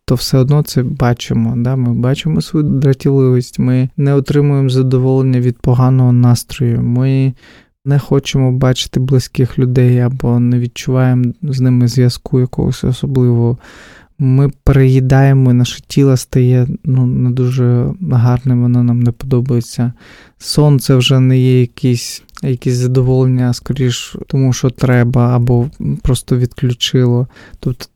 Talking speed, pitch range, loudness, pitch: 125 wpm, 125-135 Hz, -13 LUFS, 130 Hz